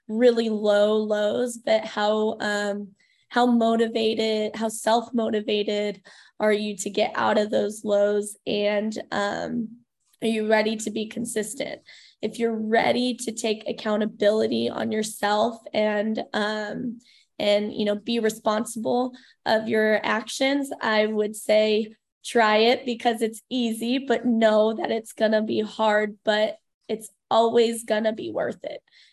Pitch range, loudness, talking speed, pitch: 210-230 Hz, -24 LUFS, 140 wpm, 220 Hz